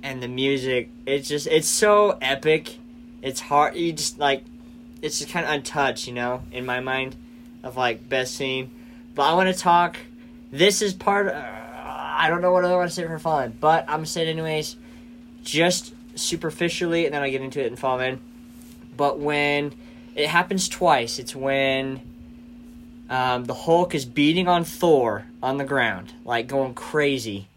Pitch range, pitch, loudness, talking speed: 130-200 Hz, 155 Hz, -23 LUFS, 185 wpm